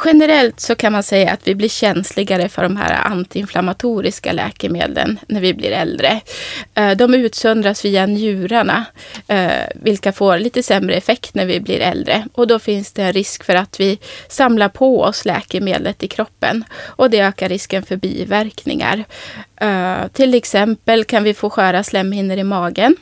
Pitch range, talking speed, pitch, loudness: 190-225 Hz, 160 wpm, 205 Hz, -16 LUFS